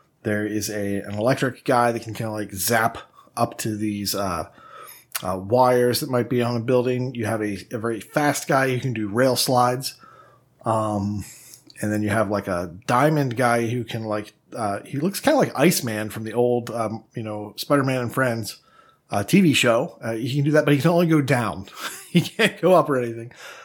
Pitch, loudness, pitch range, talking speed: 120 Hz, -22 LUFS, 105-130 Hz, 215 wpm